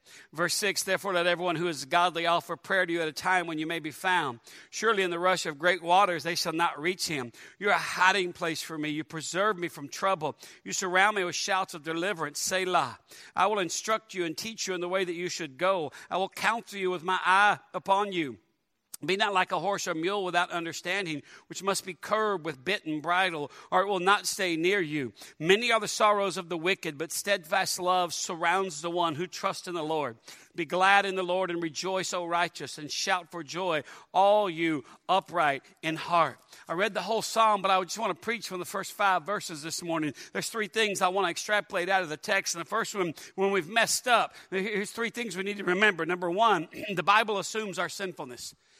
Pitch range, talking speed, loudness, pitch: 170-195 Hz, 230 wpm, -28 LUFS, 185 Hz